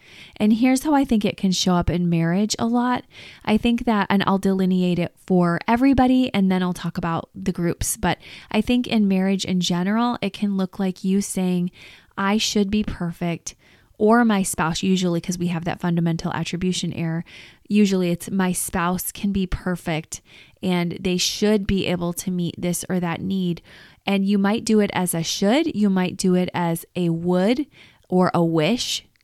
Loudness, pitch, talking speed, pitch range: -21 LUFS, 185 Hz, 190 wpm, 175-205 Hz